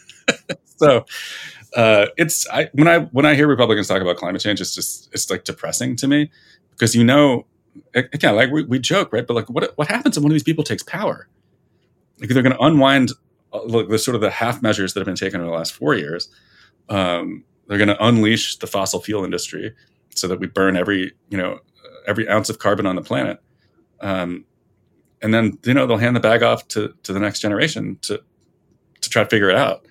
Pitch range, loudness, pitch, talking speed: 100-135 Hz, -18 LUFS, 115 Hz, 220 wpm